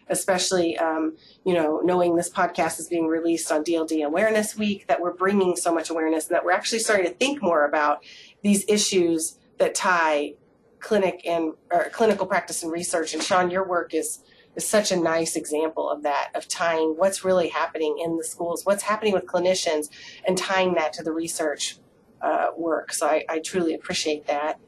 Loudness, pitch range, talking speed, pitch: -24 LUFS, 160-190 Hz, 190 wpm, 170 Hz